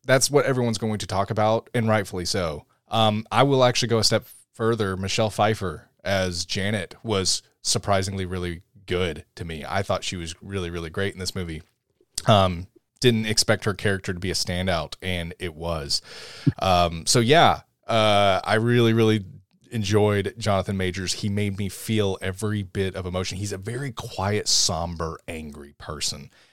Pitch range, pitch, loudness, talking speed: 90-110 Hz, 100 Hz, -23 LUFS, 170 wpm